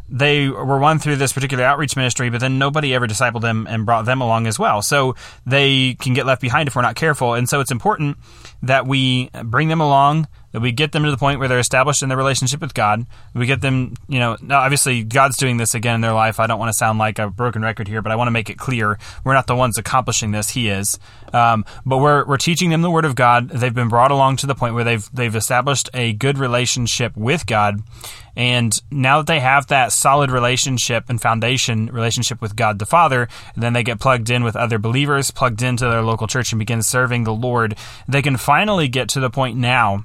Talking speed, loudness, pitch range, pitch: 240 wpm, -17 LUFS, 115-135 Hz, 125 Hz